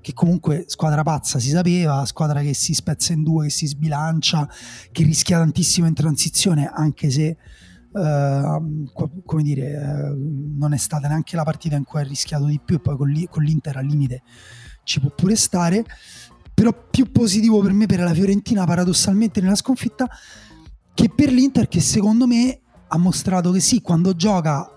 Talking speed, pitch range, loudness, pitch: 170 wpm, 145-185 Hz, -19 LUFS, 160 Hz